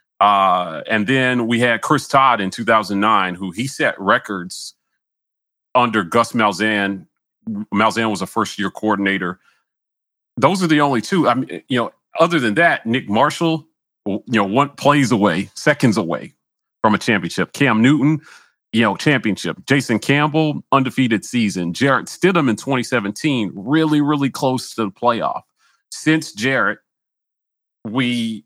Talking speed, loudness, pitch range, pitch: 145 wpm, -17 LUFS, 110-140 Hz, 120 Hz